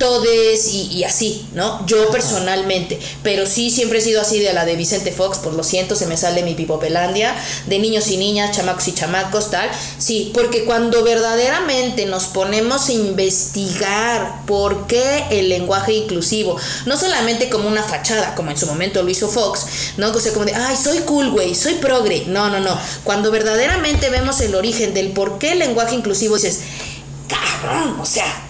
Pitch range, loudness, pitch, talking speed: 185-230 Hz, -16 LUFS, 210 Hz, 185 wpm